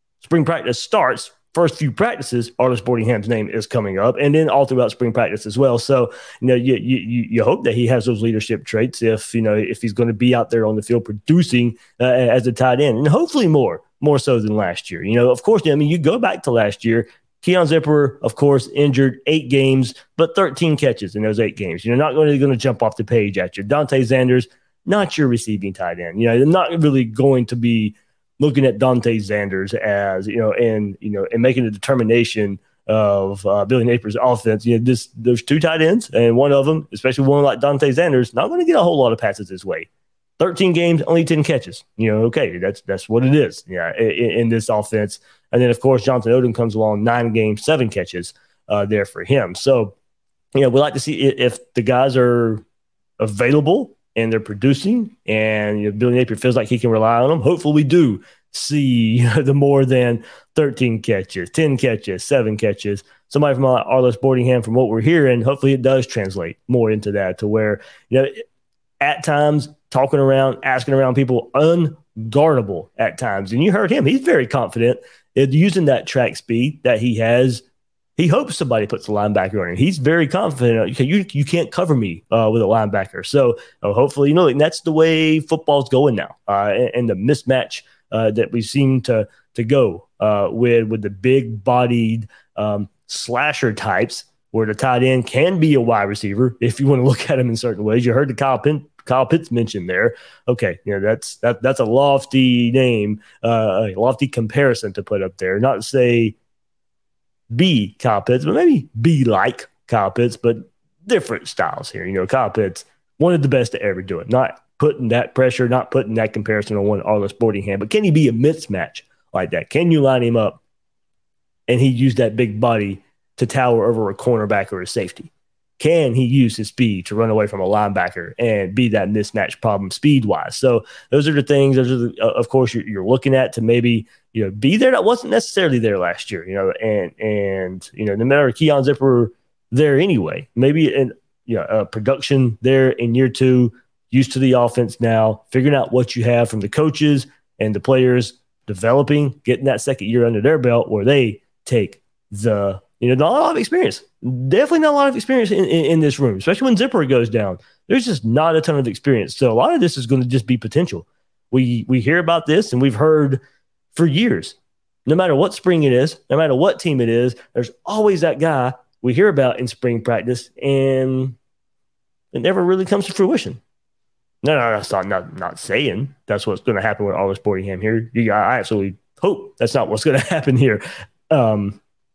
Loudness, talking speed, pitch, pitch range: -17 LUFS, 215 wpm, 125 Hz, 115-140 Hz